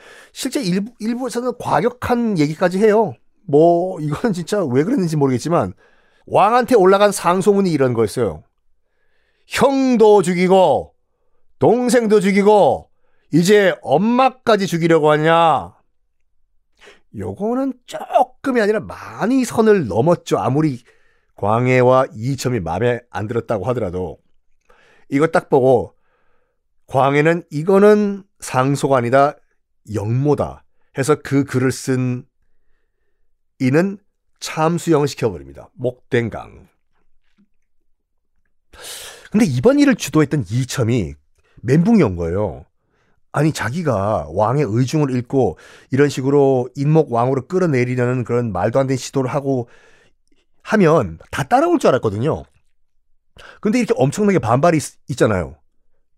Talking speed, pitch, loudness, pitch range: 255 characters per minute, 155 Hz, -17 LUFS, 125-210 Hz